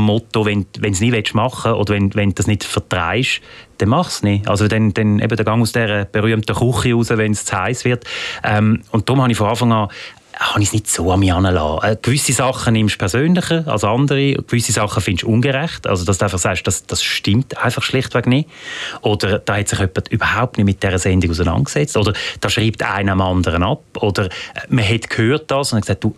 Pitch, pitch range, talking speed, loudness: 110 Hz, 100-120 Hz, 235 wpm, -17 LUFS